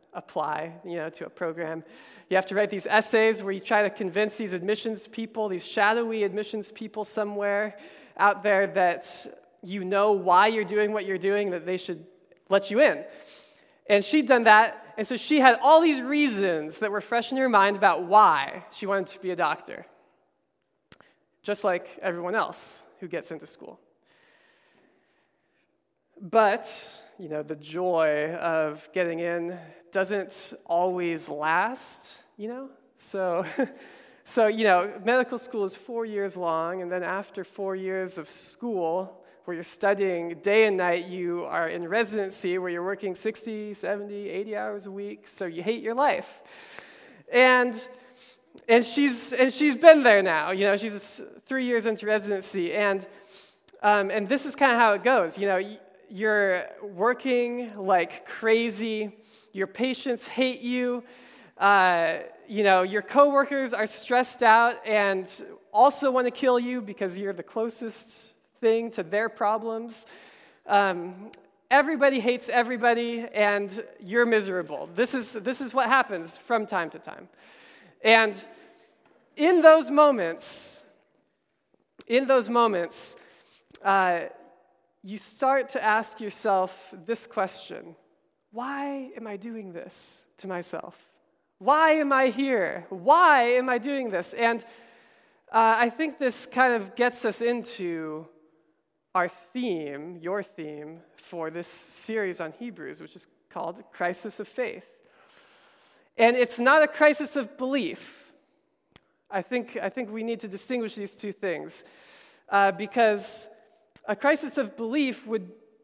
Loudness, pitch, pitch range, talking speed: -25 LUFS, 215 Hz, 190-245 Hz, 150 wpm